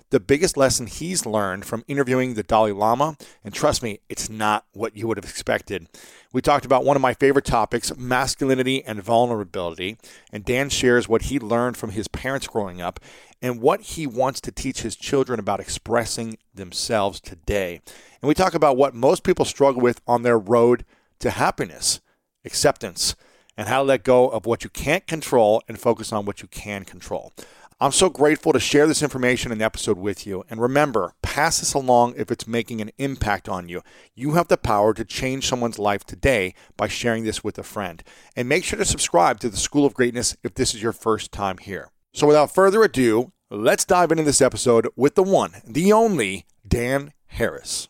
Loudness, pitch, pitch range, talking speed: -21 LUFS, 120 Hz, 110-140 Hz, 195 wpm